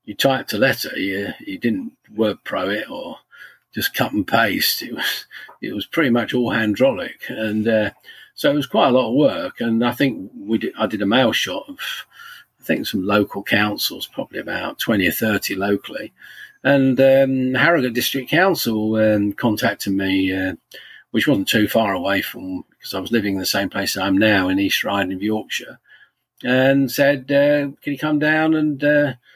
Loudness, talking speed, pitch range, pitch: -19 LUFS, 190 wpm, 105-145 Hz, 125 Hz